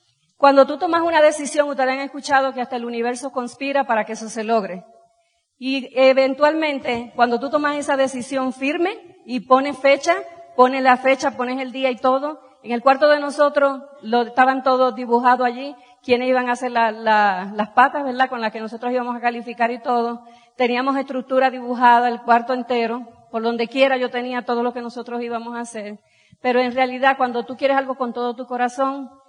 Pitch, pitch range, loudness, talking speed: 255 Hz, 240-270 Hz, -19 LUFS, 195 wpm